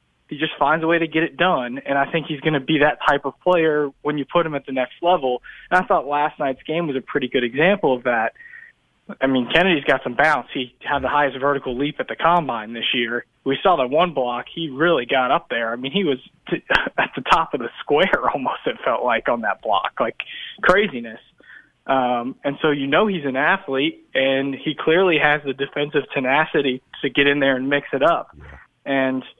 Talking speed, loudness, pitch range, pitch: 230 wpm, -20 LUFS, 135-160 Hz, 145 Hz